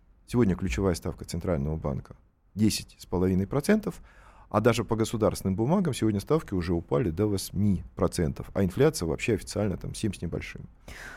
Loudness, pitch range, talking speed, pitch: -28 LUFS, 90-115 Hz, 135 wpm, 100 Hz